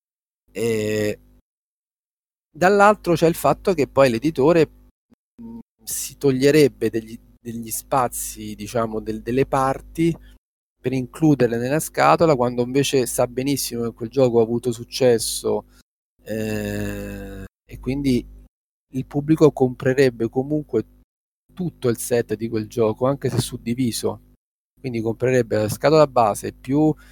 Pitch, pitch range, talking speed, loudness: 125 Hz, 115-140 Hz, 115 wpm, -21 LUFS